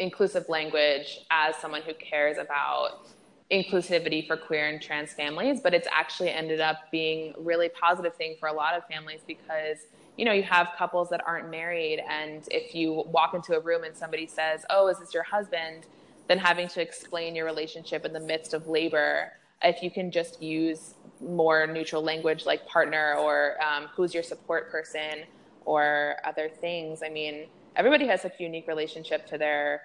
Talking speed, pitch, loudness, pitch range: 185 wpm, 160 Hz, -28 LUFS, 155-170 Hz